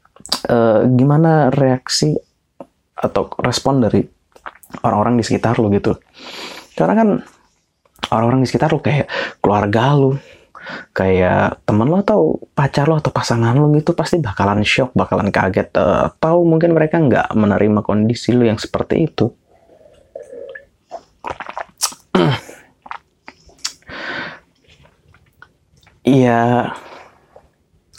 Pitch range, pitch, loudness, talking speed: 100-140 Hz, 120 Hz, -16 LUFS, 105 wpm